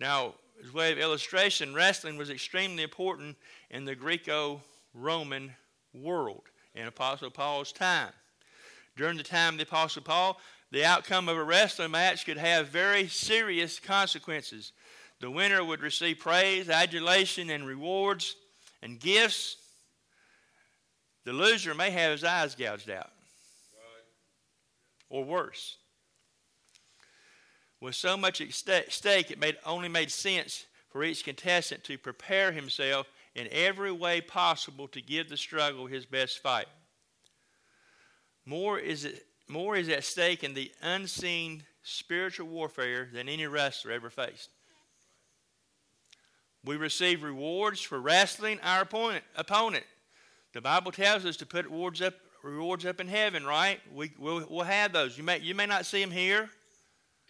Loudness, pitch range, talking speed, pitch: -29 LUFS, 145-190 Hz, 140 wpm, 165 Hz